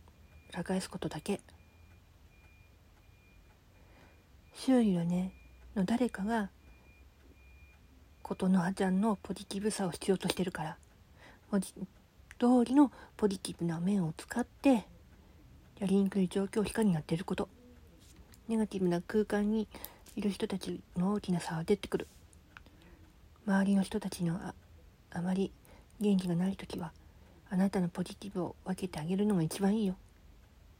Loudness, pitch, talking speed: -33 LUFS, 180 Hz, 260 characters per minute